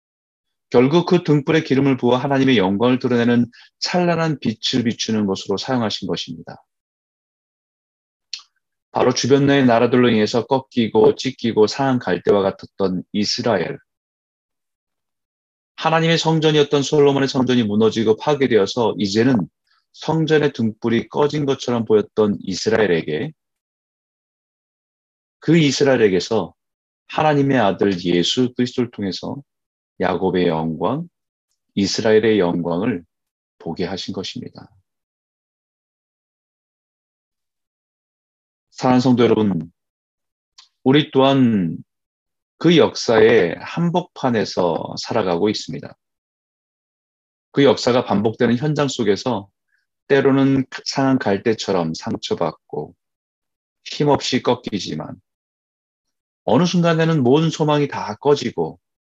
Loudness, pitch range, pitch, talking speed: -18 LUFS, 100-140 Hz, 120 Hz, 245 characters per minute